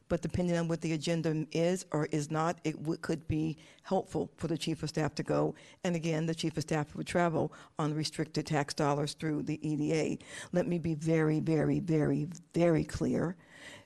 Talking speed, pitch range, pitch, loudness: 195 wpm, 150-165 Hz, 160 Hz, -33 LUFS